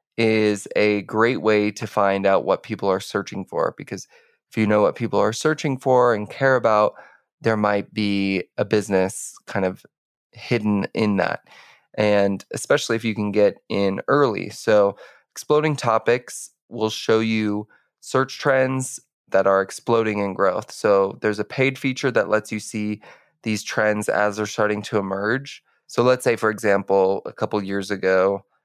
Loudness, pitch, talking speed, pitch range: -21 LUFS, 105 Hz, 170 wpm, 100-115 Hz